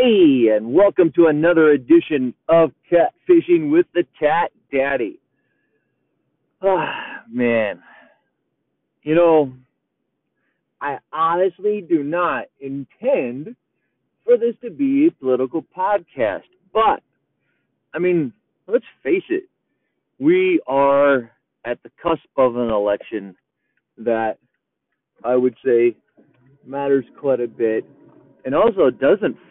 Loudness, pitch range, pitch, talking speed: -18 LUFS, 130-205 Hz, 160 Hz, 110 wpm